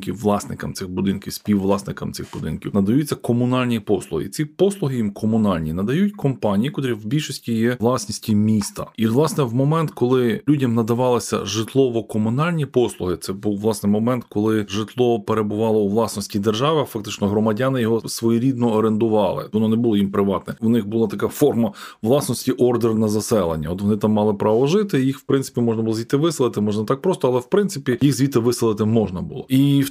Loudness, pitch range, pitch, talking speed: -20 LUFS, 105-130 Hz, 115 Hz, 170 wpm